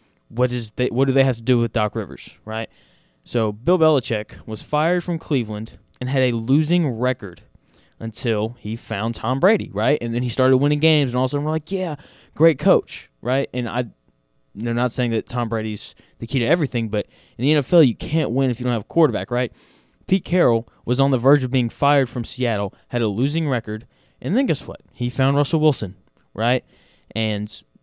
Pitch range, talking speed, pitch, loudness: 110-140 Hz, 215 wpm, 125 Hz, -21 LUFS